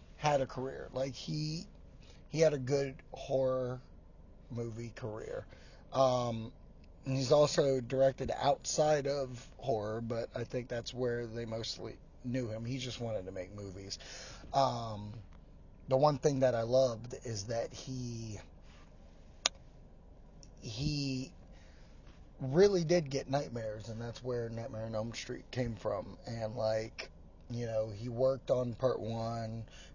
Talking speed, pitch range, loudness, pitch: 135 wpm, 110-130 Hz, -35 LUFS, 120 Hz